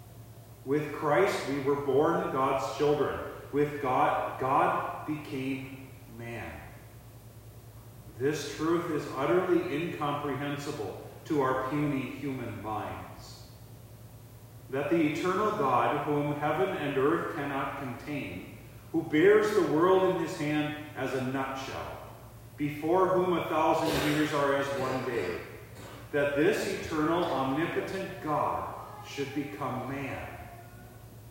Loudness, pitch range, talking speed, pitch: -30 LUFS, 115-150 Hz, 115 wpm, 135 Hz